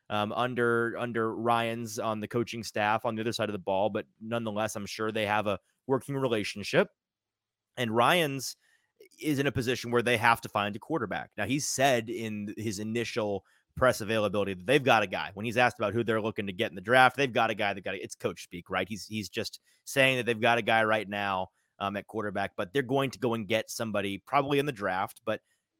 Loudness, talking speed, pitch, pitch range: -29 LUFS, 235 wpm, 115 Hz, 105-120 Hz